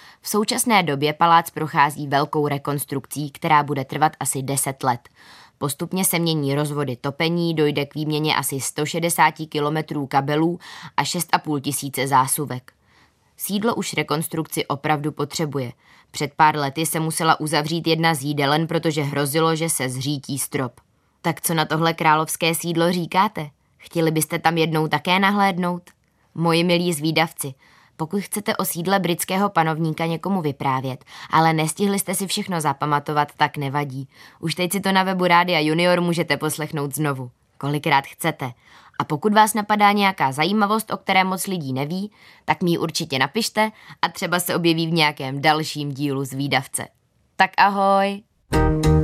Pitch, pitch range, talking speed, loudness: 155 Hz, 145-175 Hz, 150 wpm, -21 LUFS